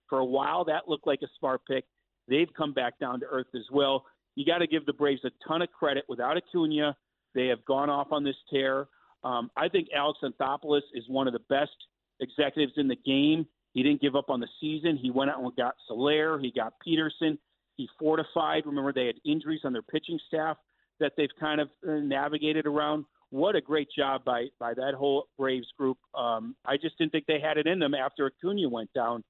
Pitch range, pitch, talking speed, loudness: 130-155 Hz, 145 Hz, 220 wpm, -29 LUFS